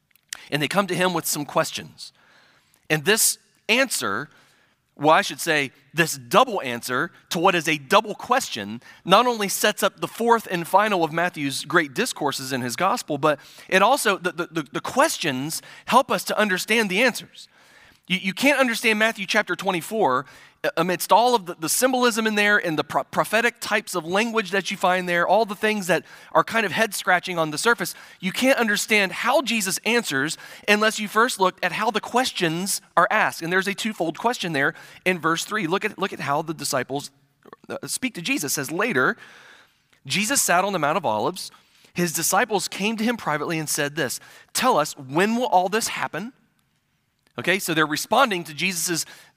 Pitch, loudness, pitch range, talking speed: 185 Hz, -22 LUFS, 160-215 Hz, 190 wpm